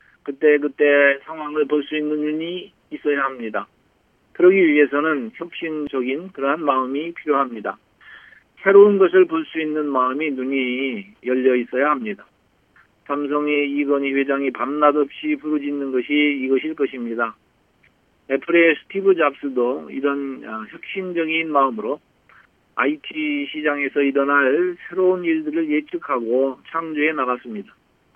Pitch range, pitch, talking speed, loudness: 135-165 Hz, 145 Hz, 290 characters per minute, -20 LUFS